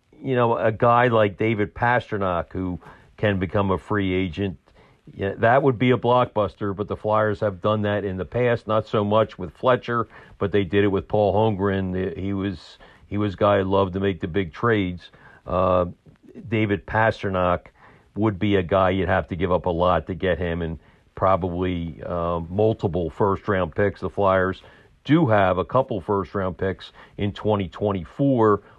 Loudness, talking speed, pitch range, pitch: -22 LUFS, 180 wpm, 90-110 Hz, 100 Hz